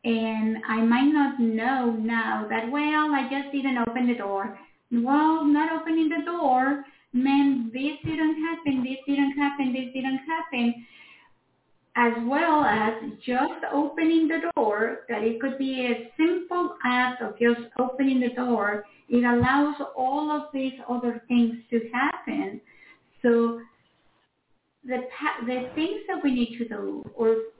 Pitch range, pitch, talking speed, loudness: 235-295 Hz, 260 Hz, 145 wpm, -25 LUFS